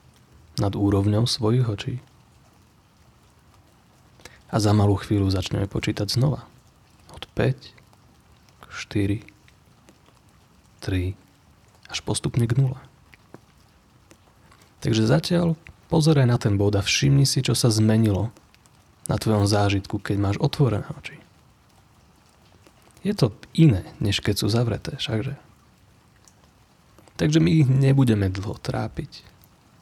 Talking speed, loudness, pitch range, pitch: 105 wpm, -23 LUFS, 100-135 Hz, 110 Hz